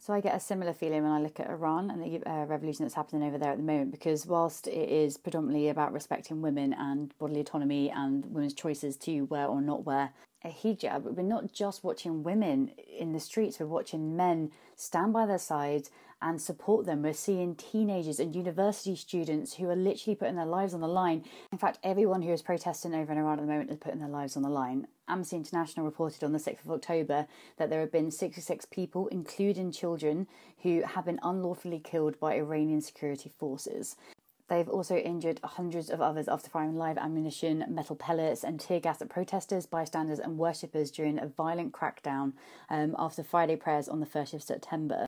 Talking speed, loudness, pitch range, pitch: 205 wpm, -33 LUFS, 150-180 Hz, 160 Hz